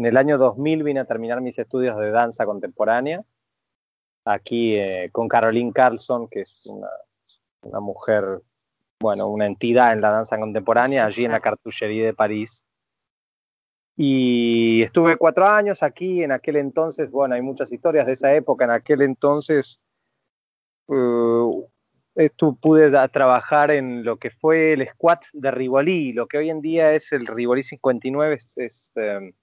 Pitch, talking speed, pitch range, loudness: 130 Hz, 160 wpm, 115-150 Hz, -20 LUFS